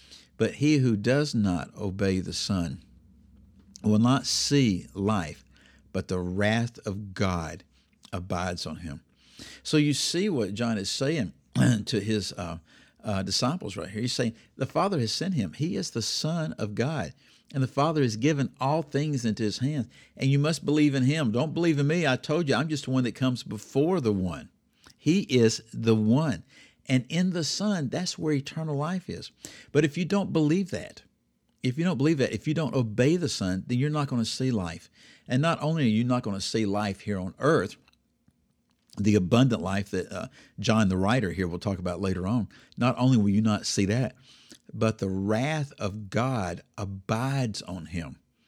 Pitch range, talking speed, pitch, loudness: 95-140 Hz, 195 wpm, 115 Hz, -27 LUFS